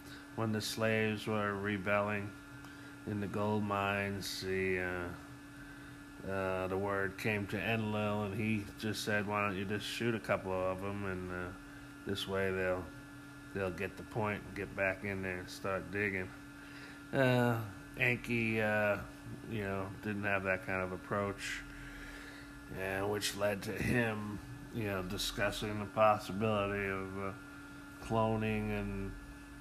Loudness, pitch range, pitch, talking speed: -36 LUFS, 95-125 Hz, 105 Hz, 145 wpm